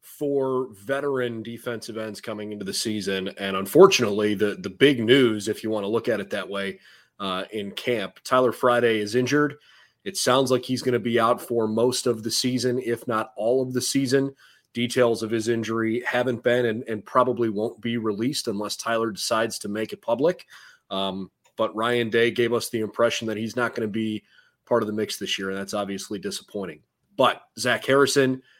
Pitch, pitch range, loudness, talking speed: 115 Hz, 110-125 Hz, -24 LUFS, 200 wpm